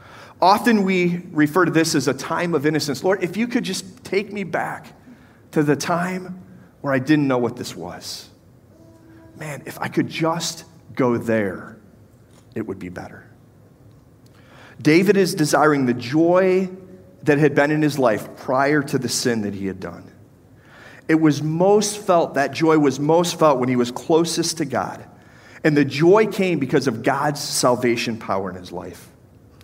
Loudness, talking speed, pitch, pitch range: -20 LUFS, 170 wpm, 145 Hz, 120-165 Hz